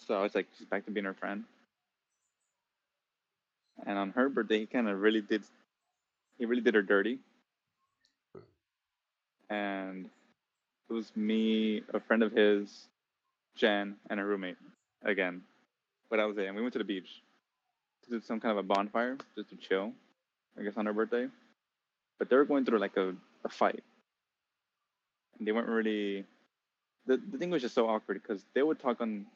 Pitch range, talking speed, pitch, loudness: 100-115 Hz, 180 wpm, 105 Hz, -33 LUFS